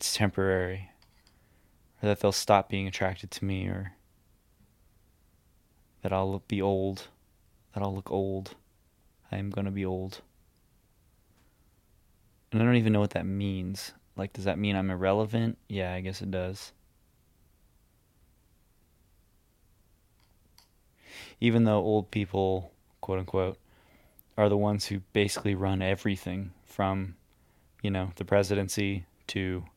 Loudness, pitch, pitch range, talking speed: -30 LUFS, 95 Hz, 95-105 Hz, 125 wpm